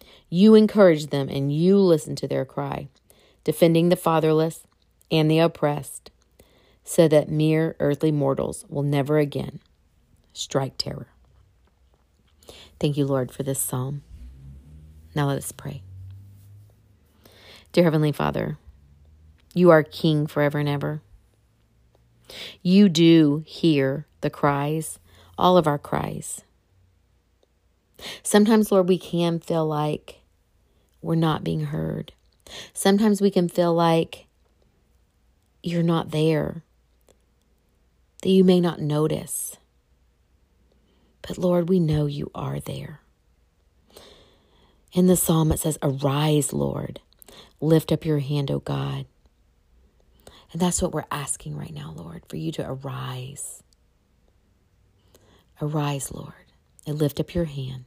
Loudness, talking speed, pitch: -22 LUFS, 120 wpm, 140 Hz